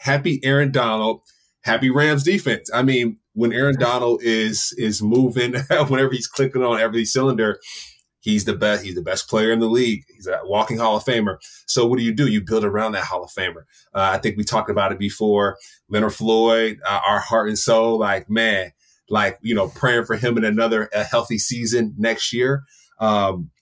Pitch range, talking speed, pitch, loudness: 110-125 Hz, 200 wpm, 115 Hz, -20 LUFS